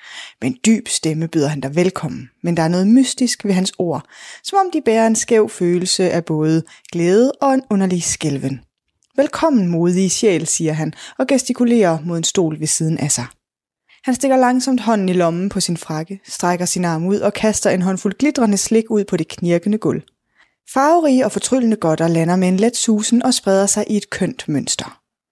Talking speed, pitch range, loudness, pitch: 195 wpm, 170-230 Hz, -17 LUFS, 195 Hz